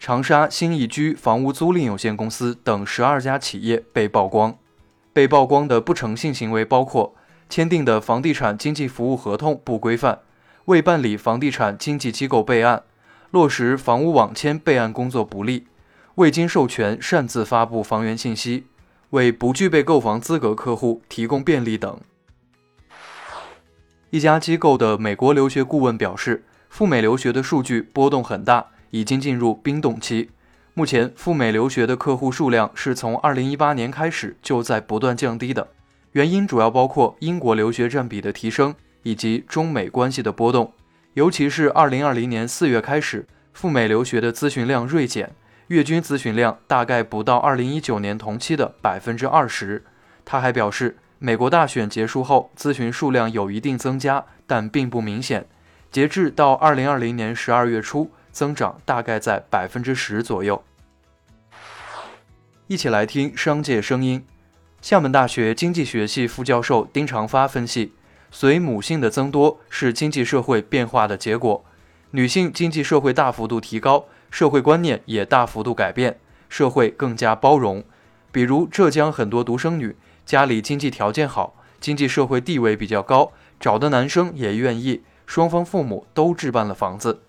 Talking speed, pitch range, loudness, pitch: 265 characters per minute, 110-145 Hz, -20 LUFS, 125 Hz